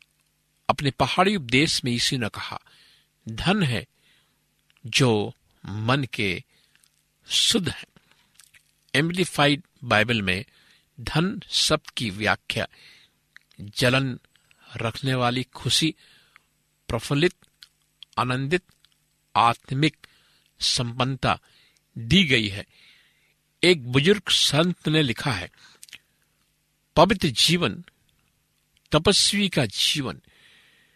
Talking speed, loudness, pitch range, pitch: 85 wpm, -23 LUFS, 115-160 Hz, 135 Hz